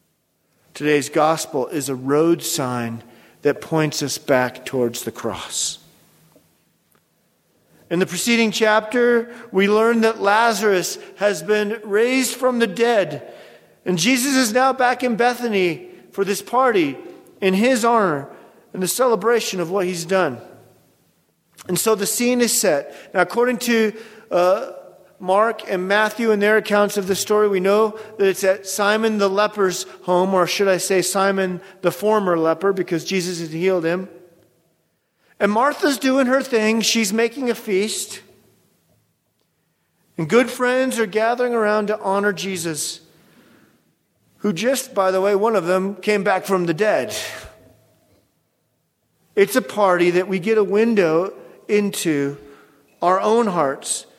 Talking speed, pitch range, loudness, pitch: 145 wpm, 180-230 Hz, -19 LUFS, 200 Hz